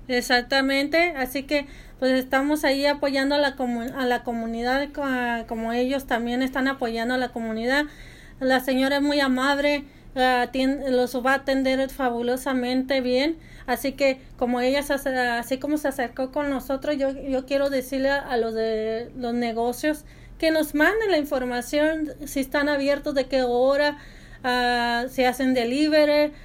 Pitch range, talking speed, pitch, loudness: 250-280 Hz, 170 wpm, 265 Hz, -24 LUFS